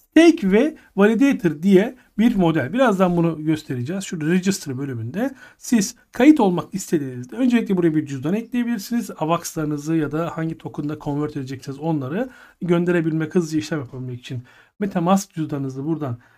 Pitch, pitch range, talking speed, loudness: 170 Hz, 150-210 Hz, 135 wpm, -21 LUFS